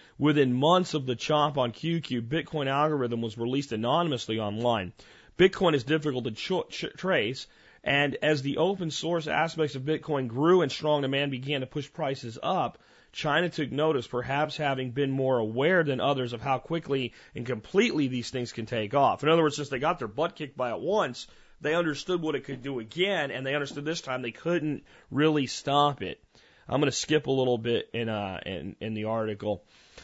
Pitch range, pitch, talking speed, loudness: 125-155 Hz, 140 Hz, 200 wpm, -28 LUFS